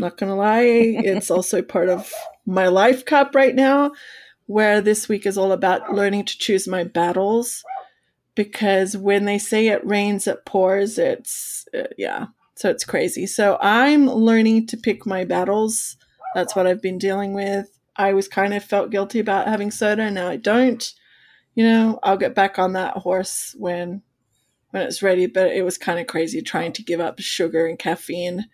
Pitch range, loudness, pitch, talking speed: 185-225 Hz, -20 LUFS, 200 Hz, 185 wpm